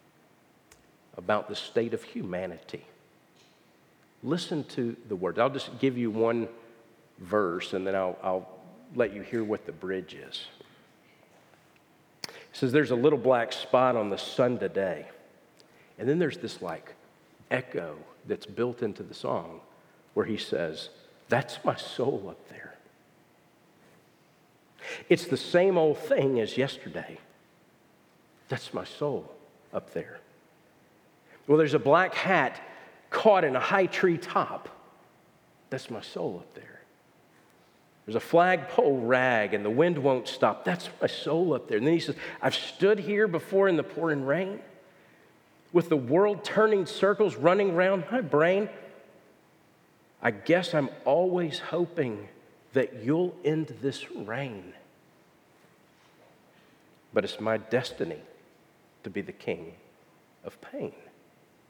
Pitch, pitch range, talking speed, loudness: 150 Hz, 120-180 Hz, 135 wpm, -28 LUFS